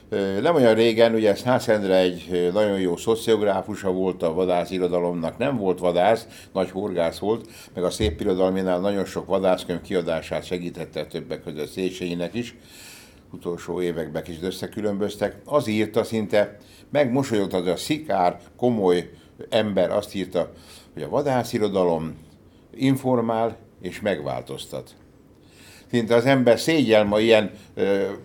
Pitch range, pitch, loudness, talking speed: 90-115 Hz, 95 Hz, -23 LUFS, 125 wpm